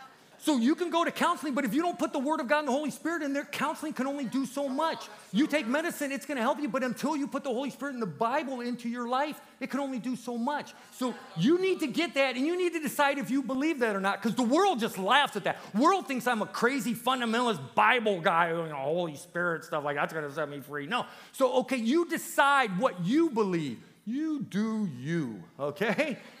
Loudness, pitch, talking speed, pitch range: -29 LUFS, 260 Hz, 245 wpm, 220-290 Hz